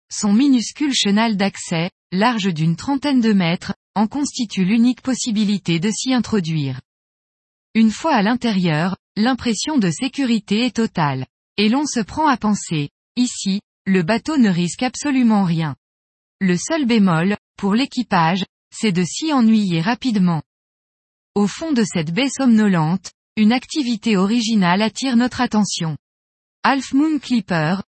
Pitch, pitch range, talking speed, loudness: 215 Hz, 185-245 Hz, 135 wpm, -18 LUFS